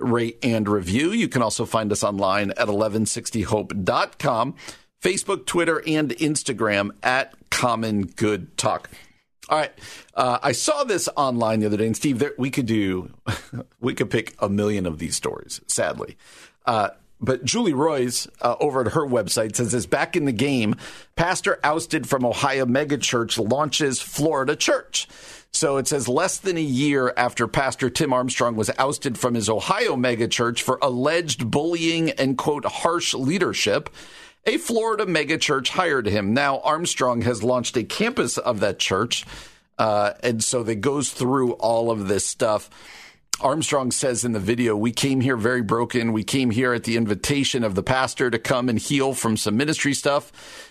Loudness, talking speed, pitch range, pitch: -22 LUFS, 170 wpm, 110-140 Hz, 125 Hz